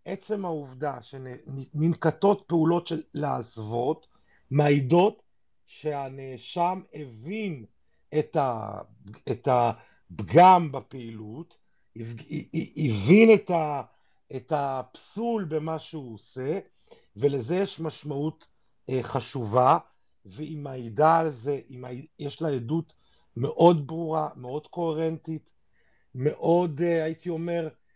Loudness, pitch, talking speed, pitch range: -26 LUFS, 150 Hz, 75 wpm, 130-165 Hz